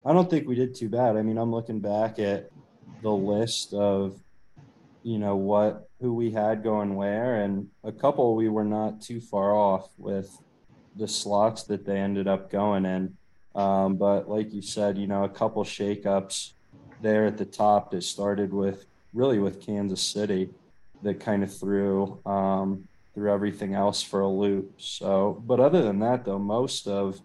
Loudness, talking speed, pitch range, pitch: -27 LUFS, 180 wpm, 100-110 Hz, 100 Hz